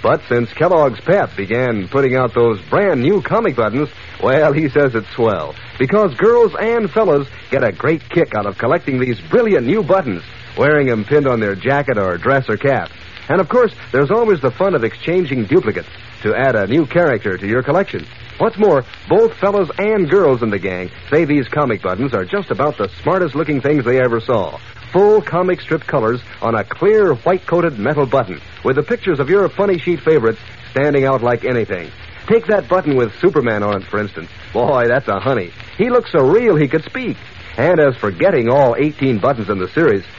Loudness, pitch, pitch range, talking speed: -15 LUFS, 140 Hz, 115-180 Hz, 205 wpm